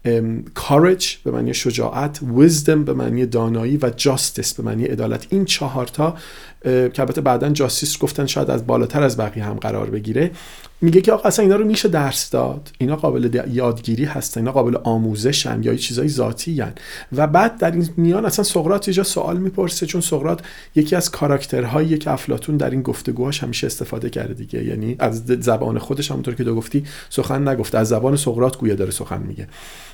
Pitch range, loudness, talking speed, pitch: 120-160 Hz, -19 LUFS, 180 wpm, 135 Hz